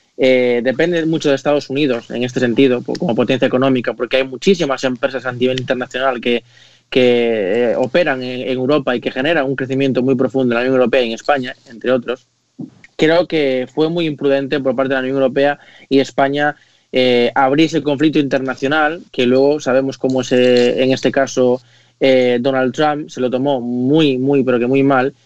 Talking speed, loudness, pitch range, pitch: 190 wpm, -15 LUFS, 125-140 Hz, 130 Hz